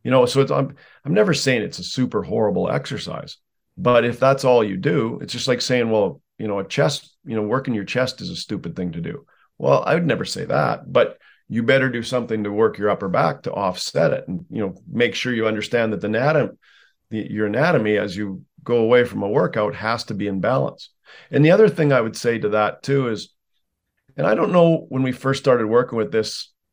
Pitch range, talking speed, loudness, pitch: 110-130 Hz, 235 wpm, -20 LUFS, 120 Hz